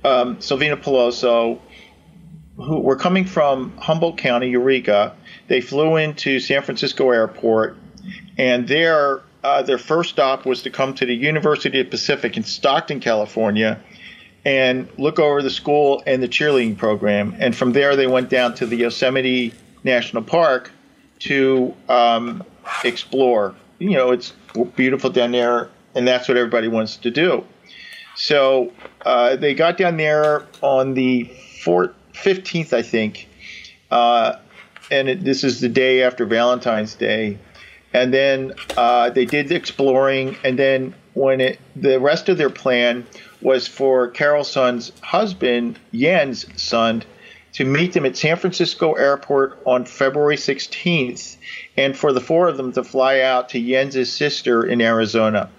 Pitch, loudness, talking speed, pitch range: 130 Hz, -18 LUFS, 150 wpm, 120-145 Hz